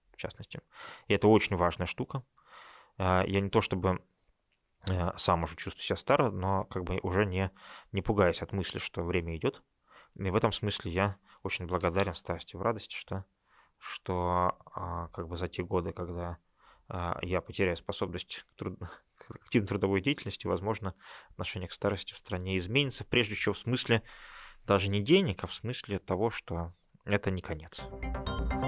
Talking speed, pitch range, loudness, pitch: 160 wpm, 90-105 Hz, -32 LUFS, 95 Hz